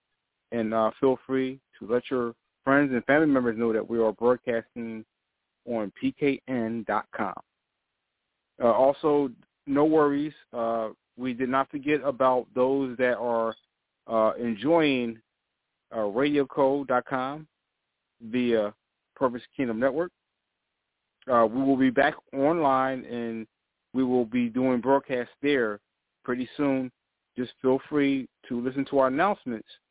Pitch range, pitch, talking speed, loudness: 115-135 Hz, 130 Hz, 125 wpm, -26 LUFS